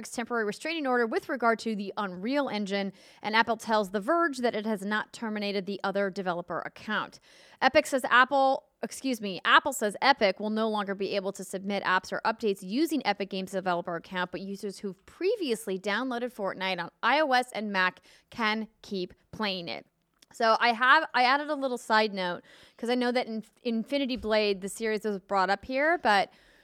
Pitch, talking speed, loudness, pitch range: 215 Hz, 185 wpm, -28 LUFS, 200-250 Hz